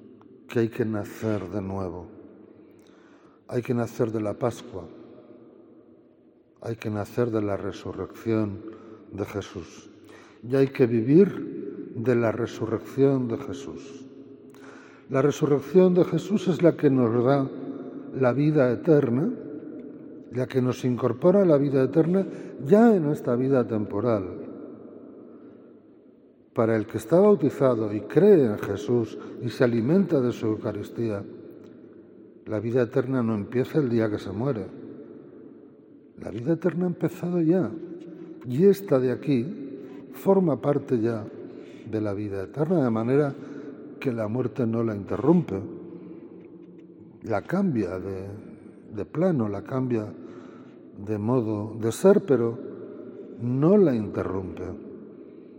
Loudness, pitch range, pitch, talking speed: -25 LUFS, 110-140 Hz, 120 Hz, 130 wpm